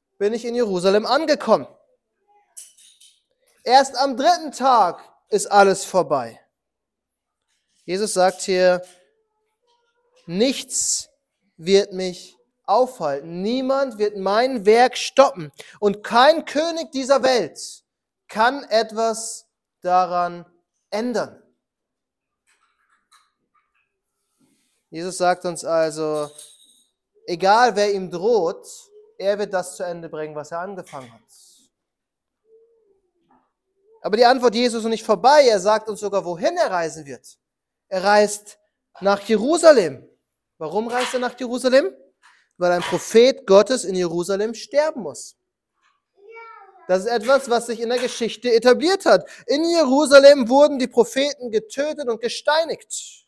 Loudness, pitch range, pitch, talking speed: -19 LUFS, 190-290 Hz, 235 Hz, 115 wpm